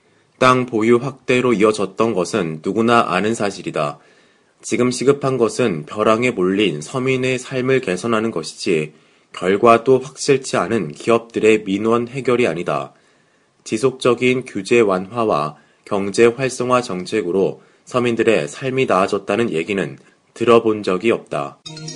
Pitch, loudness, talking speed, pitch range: 115 Hz, -18 LUFS, 285 characters per minute, 100-125 Hz